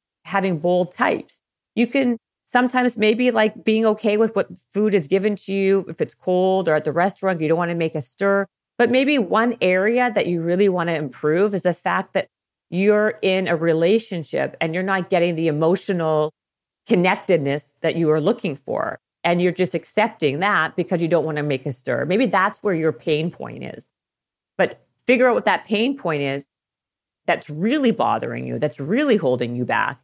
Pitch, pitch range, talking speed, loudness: 185 Hz, 155-210 Hz, 195 wpm, -20 LUFS